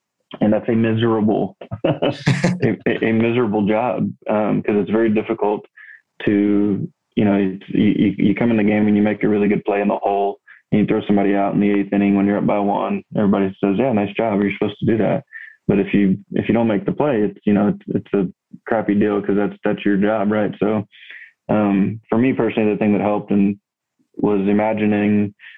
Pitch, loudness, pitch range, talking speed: 105 Hz, -18 LUFS, 100-110 Hz, 215 wpm